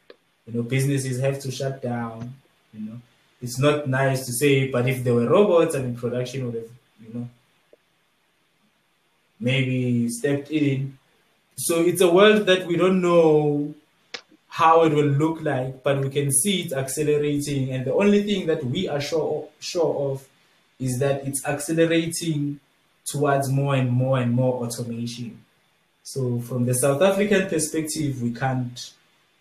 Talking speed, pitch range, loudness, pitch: 160 wpm, 125-155 Hz, -22 LUFS, 135 Hz